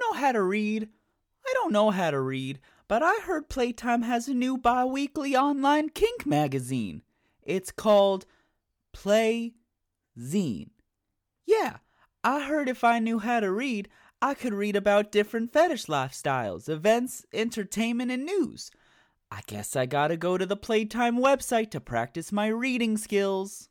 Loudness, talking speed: -27 LUFS, 150 wpm